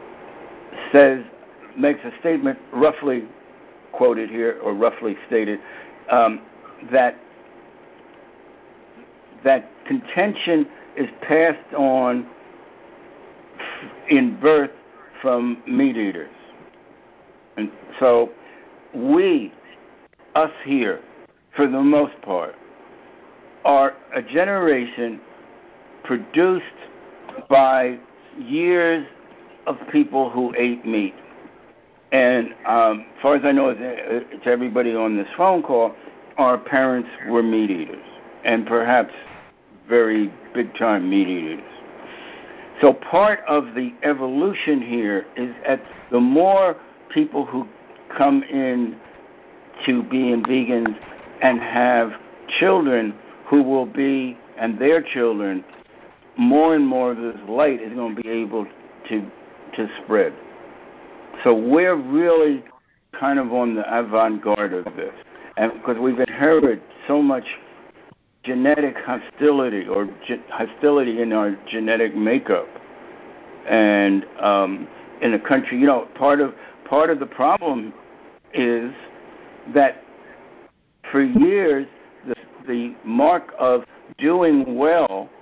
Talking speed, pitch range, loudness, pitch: 110 wpm, 115-155 Hz, -20 LUFS, 130 Hz